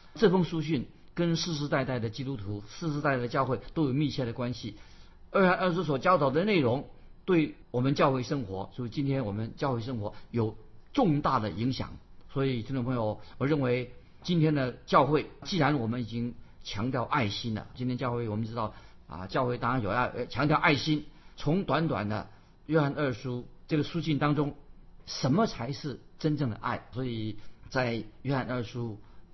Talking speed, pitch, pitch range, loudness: 270 characters per minute, 130 Hz, 115-150 Hz, -30 LUFS